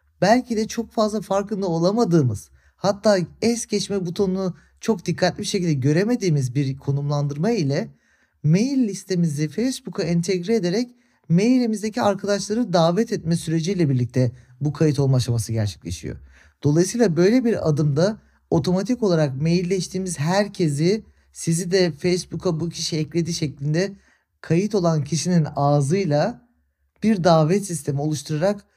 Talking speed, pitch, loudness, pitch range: 120 wpm, 175 Hz, -22 LUFS, 150-200 Hz